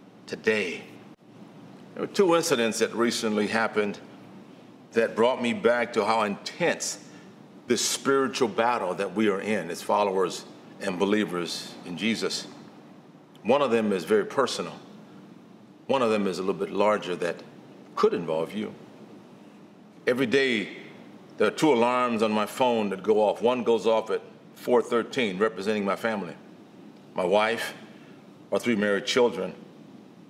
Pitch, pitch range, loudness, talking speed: 110 Hz, 100-120 Hz, -26 LUFS, 145 wpm